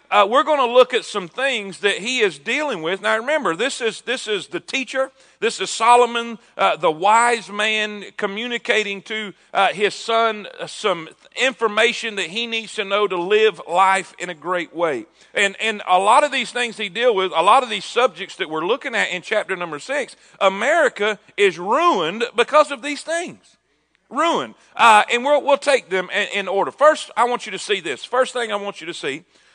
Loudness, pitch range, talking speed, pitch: -19 LUFS, 200-255 Hz, 210 wpm, 225 Hz